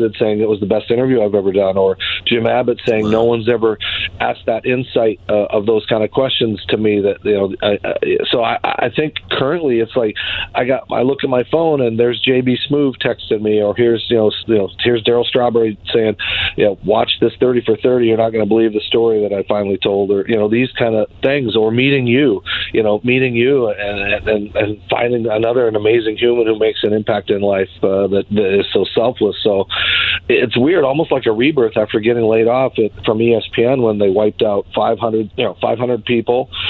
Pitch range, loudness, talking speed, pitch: 105-120 Hz, -15 LUFS, 225 wpm, 115 Hz